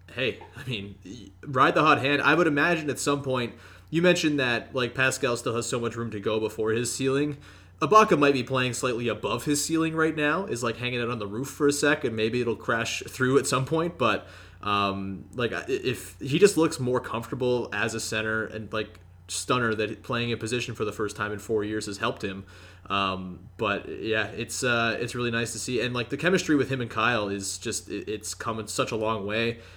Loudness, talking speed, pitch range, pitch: -26 LUFS, 225 wpm, 105-135 Hz, 115 Hz